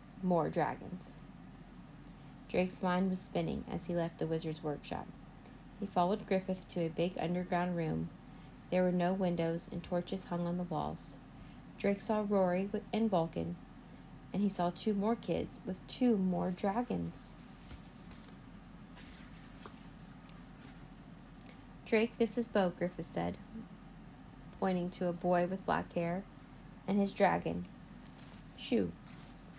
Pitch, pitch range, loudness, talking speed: 180 Hz, 170-200 Hz, -36 LUFS, 125 wpm